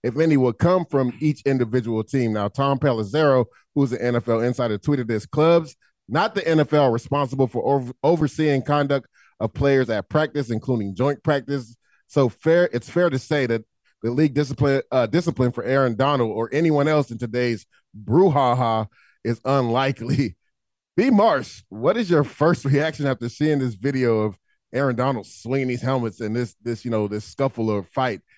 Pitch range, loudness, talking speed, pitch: 120-145 Hz, -22 LUFS, 175 wpm, 135 Hz